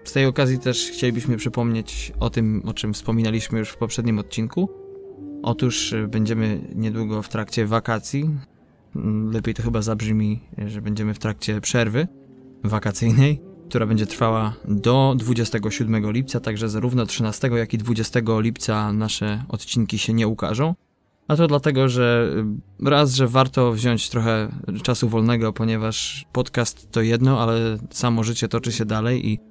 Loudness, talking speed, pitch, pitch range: -22 LUFS, 145 wpm, 115 Hz, 110-125 Hz